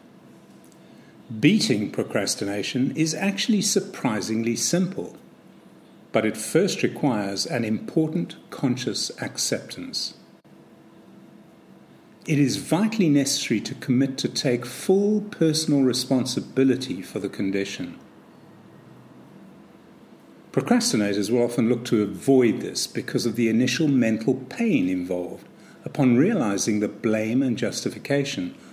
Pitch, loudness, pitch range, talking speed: 130 Hz, -23 LUFS, 115-165 Hz, 100 wpm